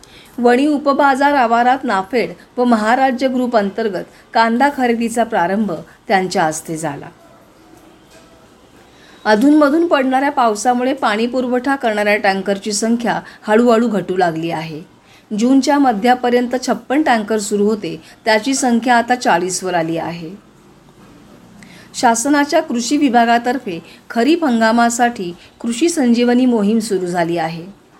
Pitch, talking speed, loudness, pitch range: 235 Hz, 105 wpm, -15 LUFS, 205-255 Hz